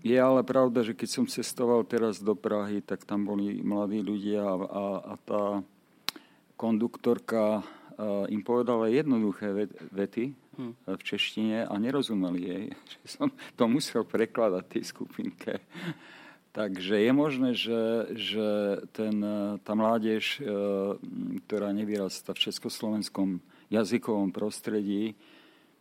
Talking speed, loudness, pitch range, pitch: 110 wpm, -30 LUFS, 100-115 Hz, 105 Hz